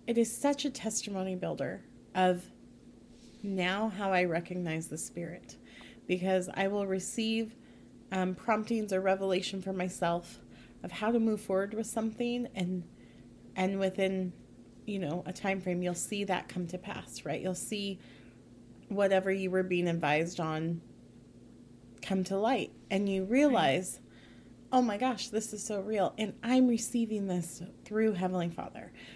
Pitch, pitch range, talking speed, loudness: 190 Hz, 180-215 Hz, 150 wpm, -32 LUFS